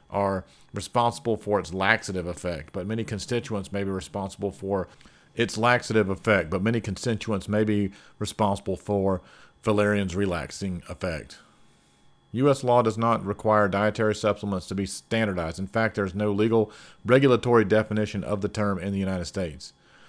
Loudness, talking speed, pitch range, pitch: -26 LUFS, 150 wpm, 95-110 Hz, 105 Hz